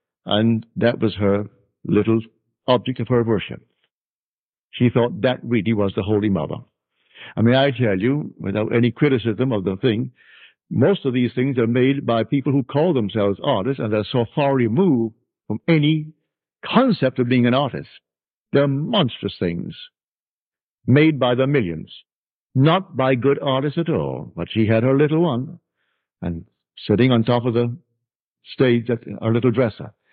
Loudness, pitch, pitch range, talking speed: -20 LUFS, 120 Hz, 110-135 Hz, 165 wpm